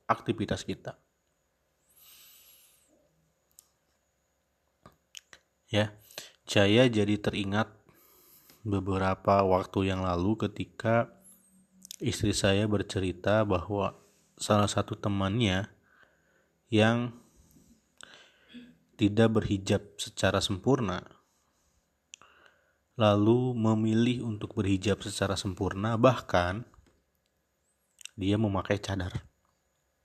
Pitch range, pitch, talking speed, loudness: 90-110 Hz, 100 Hz, 65 wpm, -29 LUFS